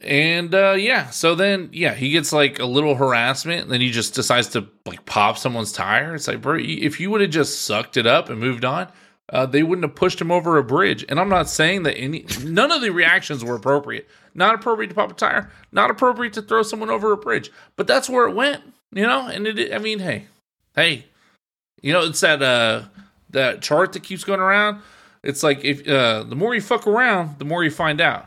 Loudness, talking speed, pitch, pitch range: -19 LUFS, 230 wpm, 160 Hz, 135-195 Hz